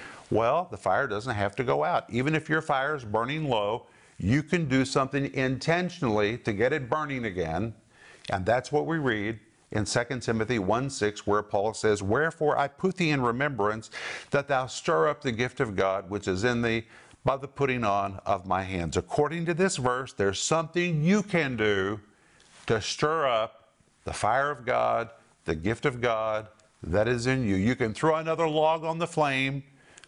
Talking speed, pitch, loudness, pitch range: 190 wpm, 125 Hz, -27 LUFS, 105-150 Hz